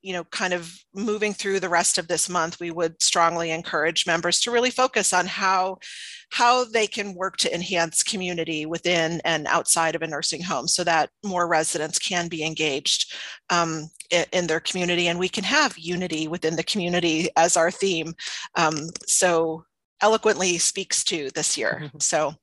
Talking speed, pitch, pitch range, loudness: 175 wpm, 175 Hz, 165-190 Hz, -22 LUFS